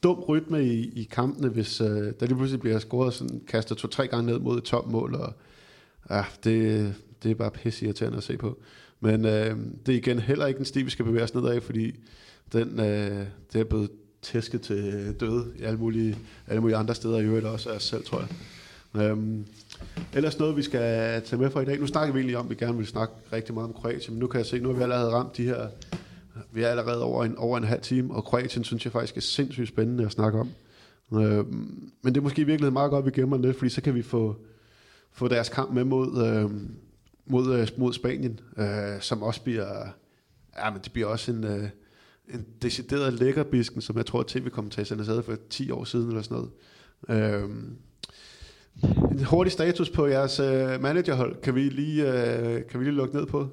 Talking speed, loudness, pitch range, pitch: 220 wpm, -27 LUFS, 110-130 Hz, 120 Hz